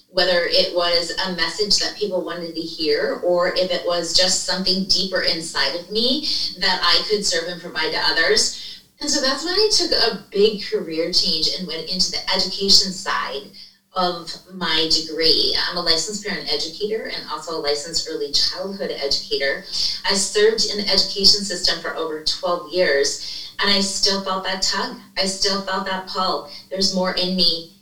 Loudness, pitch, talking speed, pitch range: -19 LUFS, 185 Hz, 180 wpm, 170-200 Hz